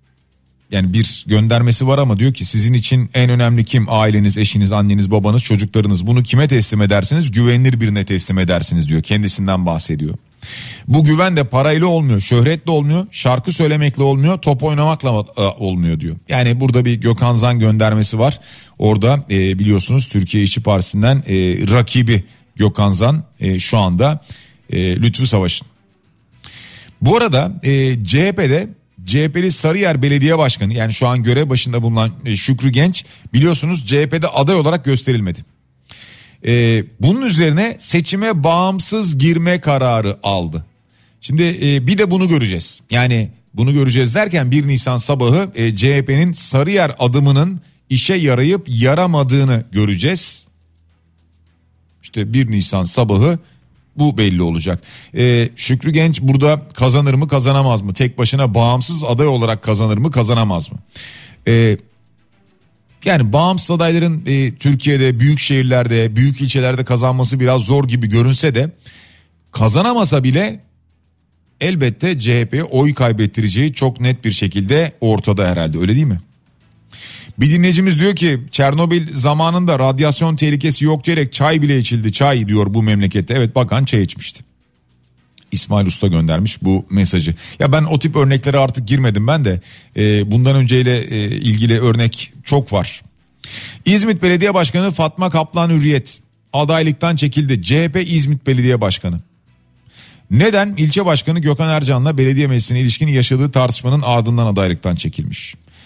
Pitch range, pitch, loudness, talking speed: 105-150 Hz, 125 Hz, -14 LUFS, 130 wpm